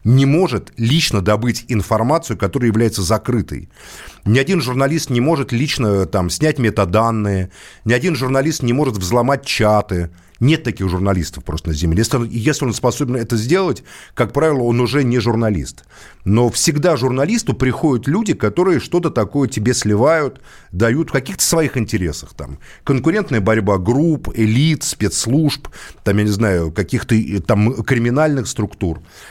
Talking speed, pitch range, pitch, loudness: 150 wpm, 100-135 Hz, 115 Hz, -17 LUFS